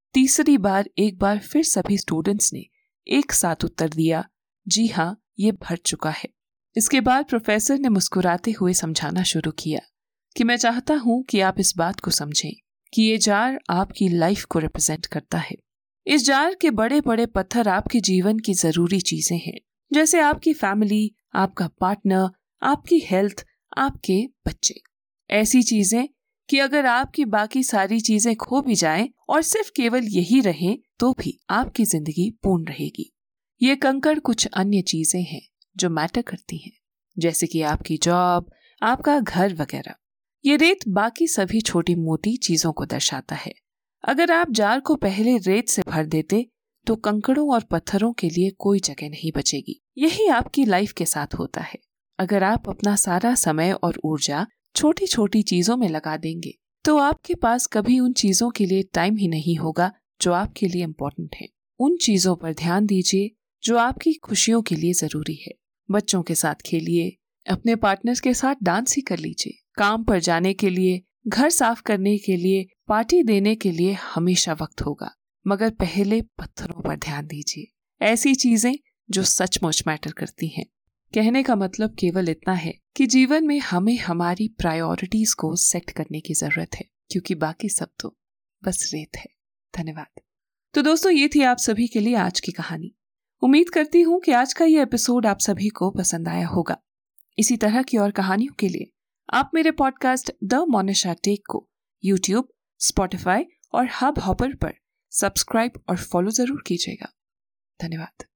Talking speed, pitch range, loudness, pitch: 170 wpm, 175-245 Hz, -21 LUFS, 205 Hz